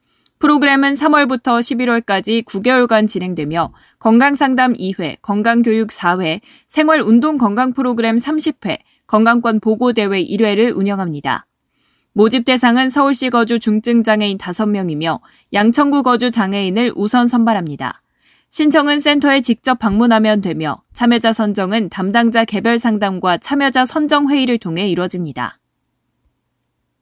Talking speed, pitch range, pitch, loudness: 290 characters per minute, 200-255 Hz, 230 Hz, -14 LUFS